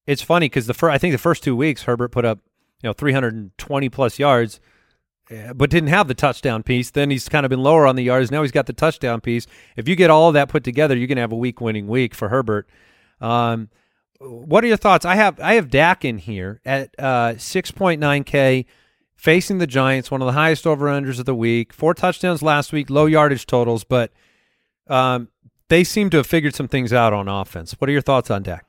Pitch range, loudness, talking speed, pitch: 120-155 Hz, -18 LUFS, 225 wpm, 135 Hz